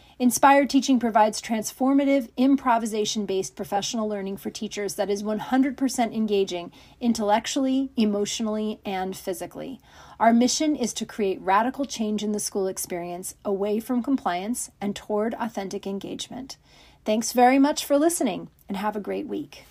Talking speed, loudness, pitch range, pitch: 140 wpm, -24 LUFS, 200-250 Hz, 215 Hz